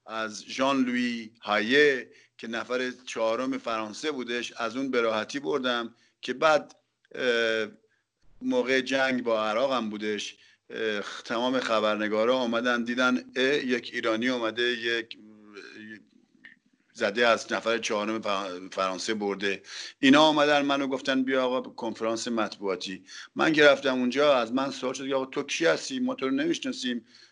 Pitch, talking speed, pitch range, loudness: 120 Hz, 130 wpm, 110-135 Hz, -27 LUFS